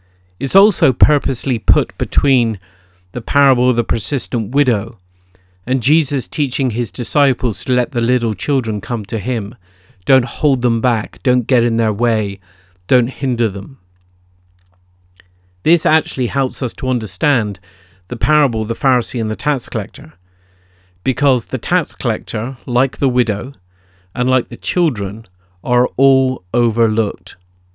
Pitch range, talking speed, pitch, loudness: 95-130 Hz, 140 wpm, 120 Hz, -16 LUFS